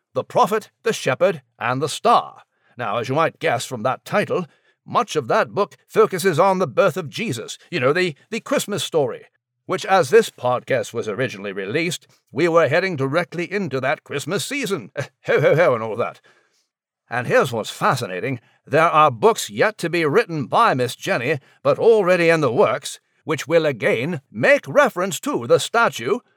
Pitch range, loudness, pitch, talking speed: 150-220 Hz, -20 LUFS, 180 Hz, 180 wpm